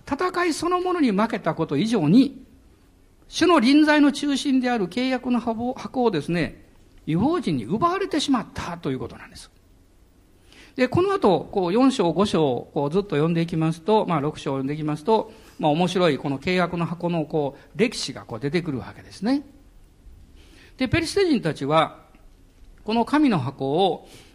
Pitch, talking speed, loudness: 180 Hz, 320 characters per minute, -22 LUFS